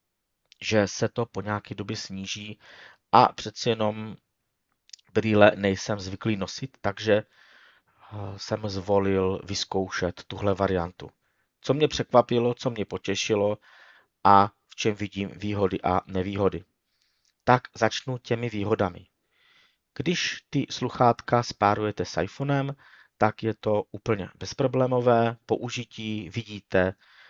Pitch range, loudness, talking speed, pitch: 95-120 Hz, -26 LUFS, 110 wpm, 105 Hz